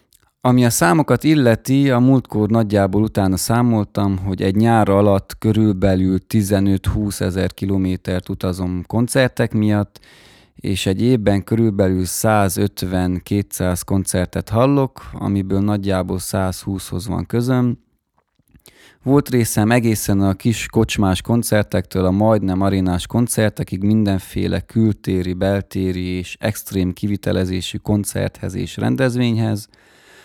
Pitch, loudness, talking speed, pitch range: 100 Hz, -18 LUFS, 105 wpm, 95-115 Hz